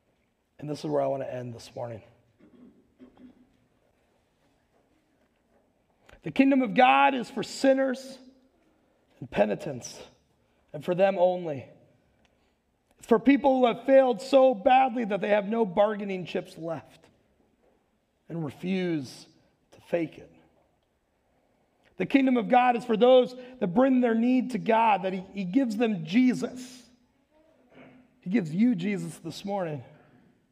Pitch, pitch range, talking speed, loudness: 225 Hz, 175-255 Hz, 130 wpm, -25 LUFS